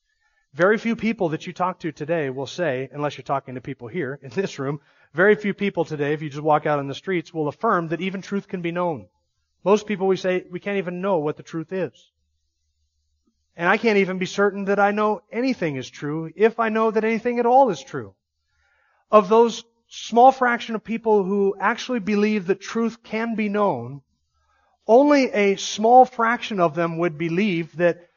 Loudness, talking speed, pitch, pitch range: -21 LUFS, 200 wpm, 185 Hz, 150-215 Hz